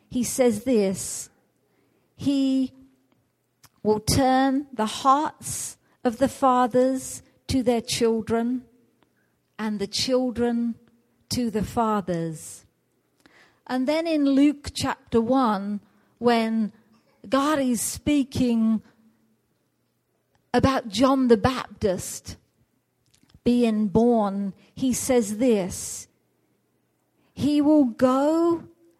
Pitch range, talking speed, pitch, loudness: 220-265 Hz, 85 wpm, 245 Hz, -23 LUFS